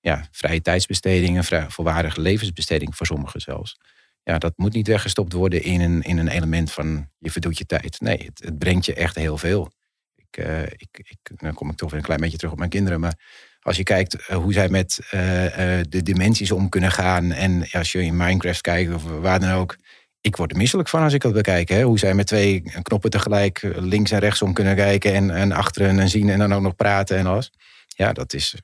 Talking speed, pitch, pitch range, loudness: 235 wpm, 90 Hz, 85-100 Hz, -21 LUFS